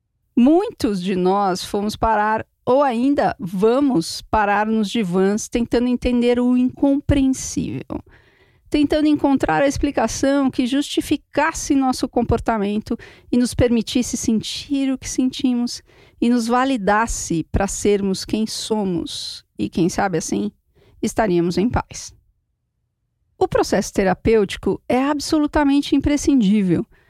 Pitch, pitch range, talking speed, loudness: 245 Hz, 210-280 Hz, 110 wpm, -19 LUFS